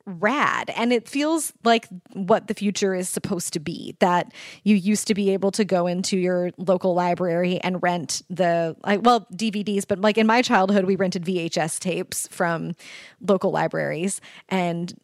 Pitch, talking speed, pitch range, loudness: 195 Hz, 170 wpm, 180-210 Hz, -23 LUFS